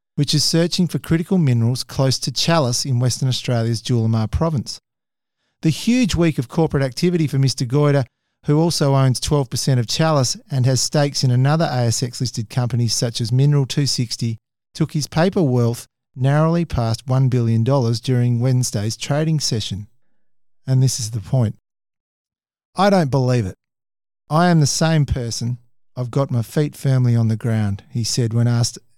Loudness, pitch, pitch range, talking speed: -19 LUFS, 130 Hz, 120-150 Hz, 165 wpm